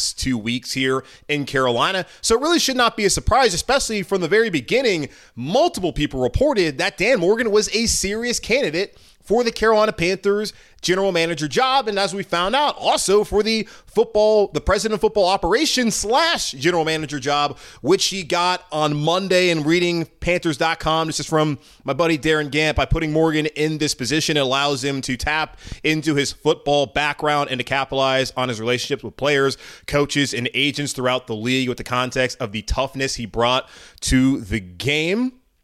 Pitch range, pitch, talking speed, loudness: 135-195 Hz, 155 Hz, 180 wpm, -20 LUFS